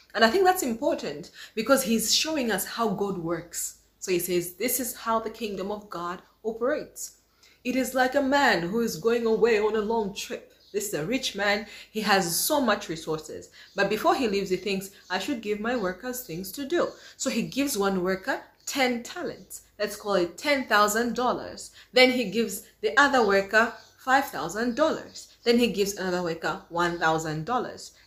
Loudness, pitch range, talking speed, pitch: -26 LUFS, 195-255 Hz, 180 wpm, 220 Hz